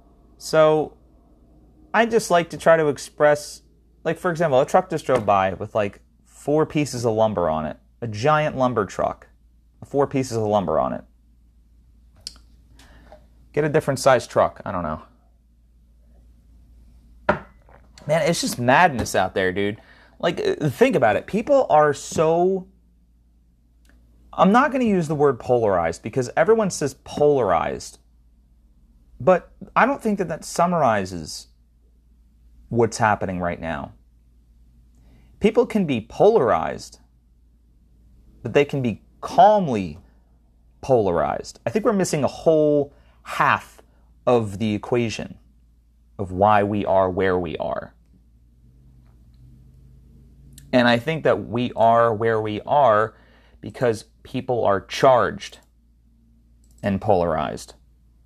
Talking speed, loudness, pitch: 125 wpm, -21 LUFS, 90 Hz